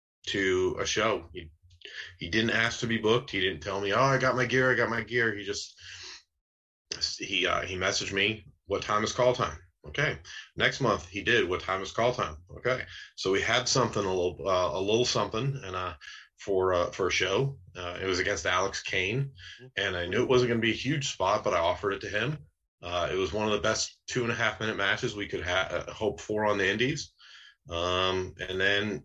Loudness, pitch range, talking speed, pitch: -28 LUFS, 95-125 Hz, 225 wpm, 105 Hz